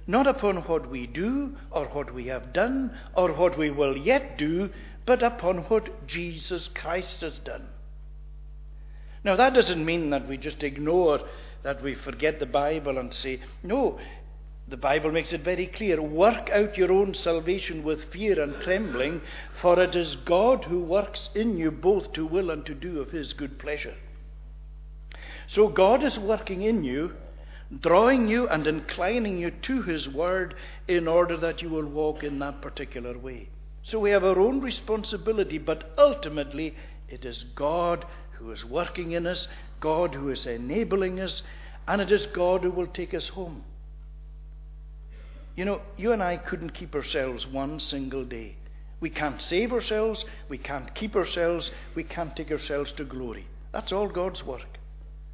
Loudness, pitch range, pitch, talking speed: -27 LUFS, 135-190 Hz, 165 Hz, 170 wpm